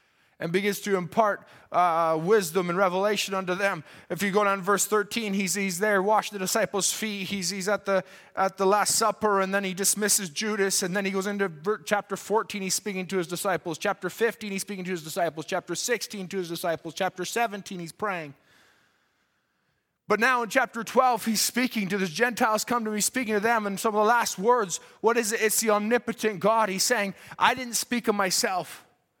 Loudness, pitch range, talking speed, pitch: -26 LUFS, 190-220 Hz, 210 wpm, 200 Hz